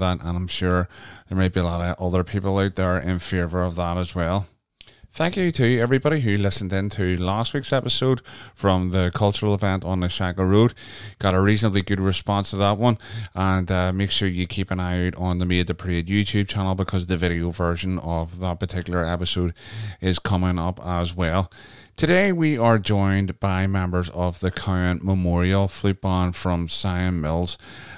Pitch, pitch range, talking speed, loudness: 95 Hz, 90-100 Hz, 195 wpm, -23 LUFS